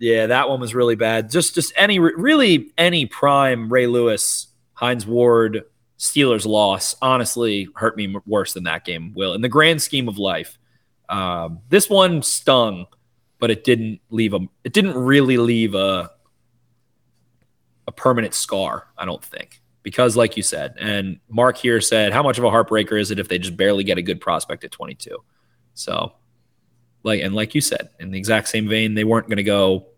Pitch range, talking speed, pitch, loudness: 105-125 Hz, 190 wpm, 115 Hz, -18 LUFS